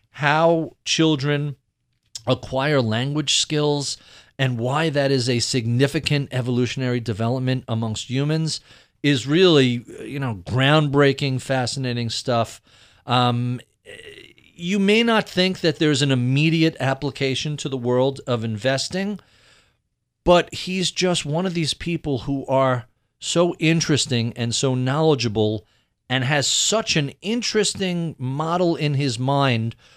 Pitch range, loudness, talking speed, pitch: 125-160 Hz, -21 LUFS, 120 wpm, 135 Hz